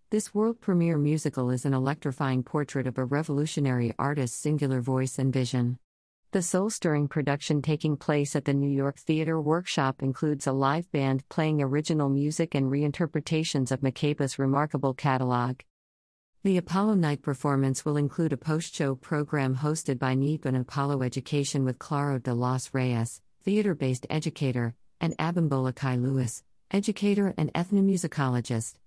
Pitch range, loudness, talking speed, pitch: 130-155 Hz, -28 LUFS, 150 wpm, 140 Hz